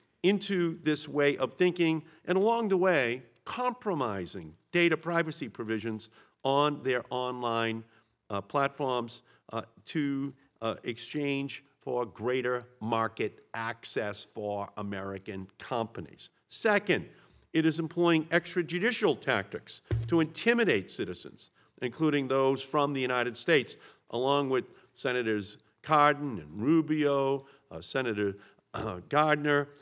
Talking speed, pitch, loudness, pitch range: 110 wpm, 135 Hz, -30 LUFS, 115-160 Hz